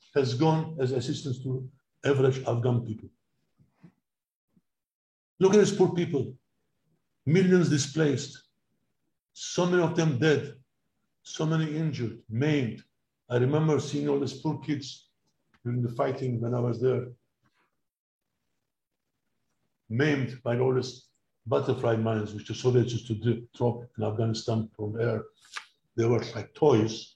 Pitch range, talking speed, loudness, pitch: 120-145 Hz, 130 wpm, -28 LUFS, 130 Hz